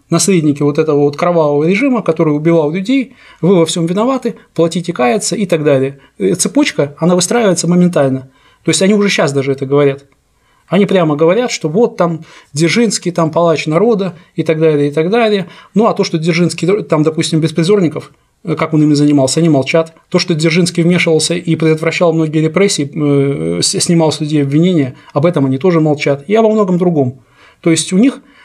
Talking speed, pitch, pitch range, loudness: 180 wpm, 165 Hz, 150-190 Hz, -12 LUFS